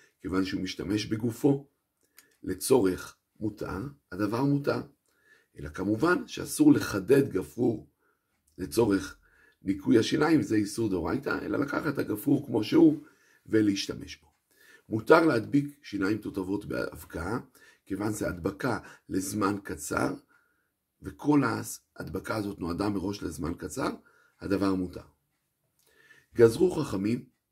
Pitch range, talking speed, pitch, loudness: 100-140 Hz, 105 wpm, 110 Hz, -28 LUFS